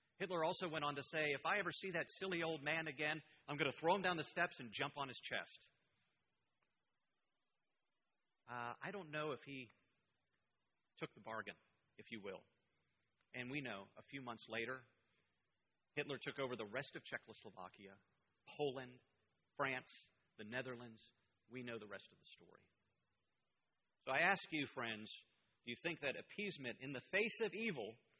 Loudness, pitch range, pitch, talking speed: -44 LUFS, 120-160 Hz, 140 Hz, 170 wpm